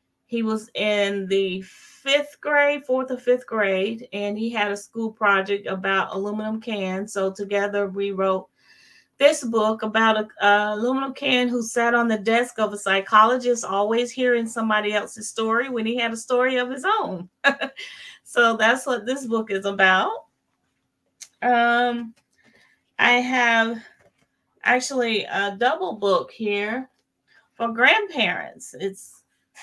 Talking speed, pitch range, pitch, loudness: 140 wpm, 205-245 Hz, 225 Hz, -22 LUFS